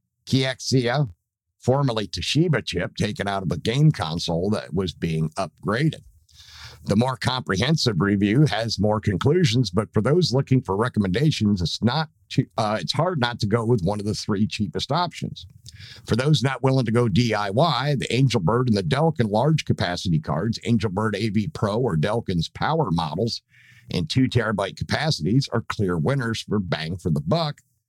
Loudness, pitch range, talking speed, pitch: -23 LUFS, 100-135 Hz, 165 wpm, 115 Hz